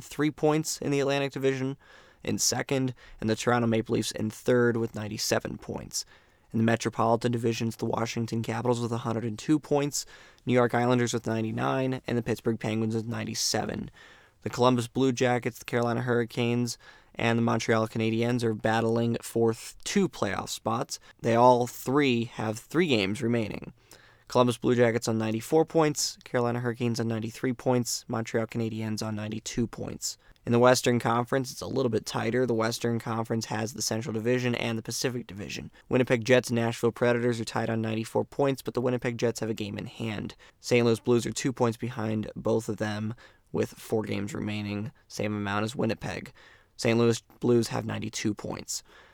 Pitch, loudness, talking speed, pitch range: 115 Hz, -28 LUFS, 175 wpm, 110-125 Hz